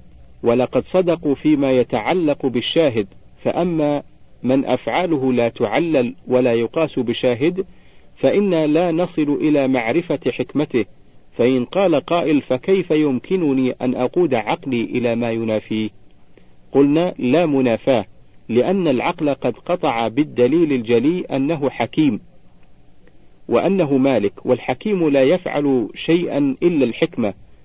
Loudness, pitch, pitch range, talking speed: -18 LUFS, 135 Hz, 120-160 Hz, 105 wpm